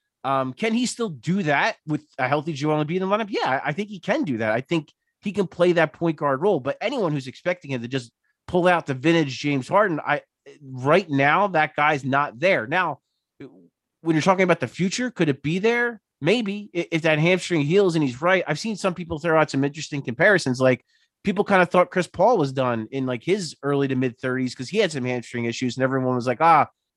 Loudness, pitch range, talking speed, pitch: -22 LUFS, 135-185 Hz, 240 wpm, 155 Hz